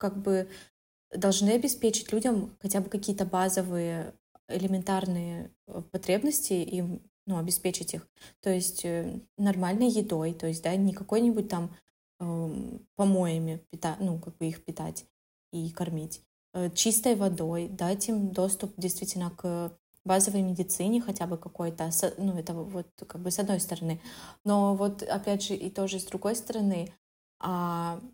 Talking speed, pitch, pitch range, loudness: 140 wpm, 185 Hz, 170-200 Hz, -30 LUFS